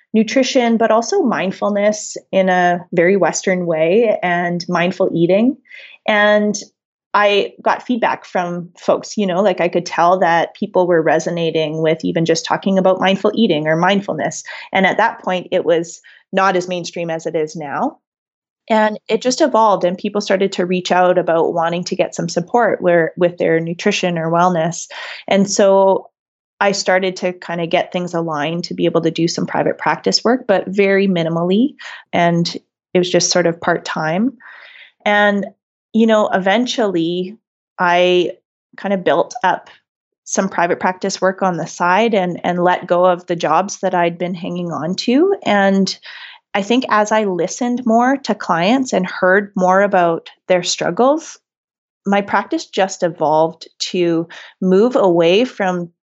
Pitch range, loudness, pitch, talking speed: 175-205 Hz, -16 LUFS, 185 Hz, 165 wpm